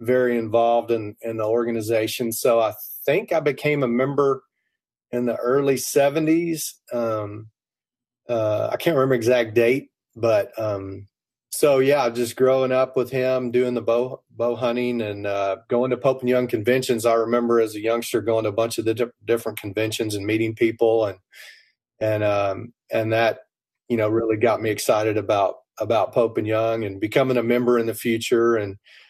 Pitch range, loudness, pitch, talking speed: 110-125 Hz, -22 LUFS, 115 Hz, 180 wpm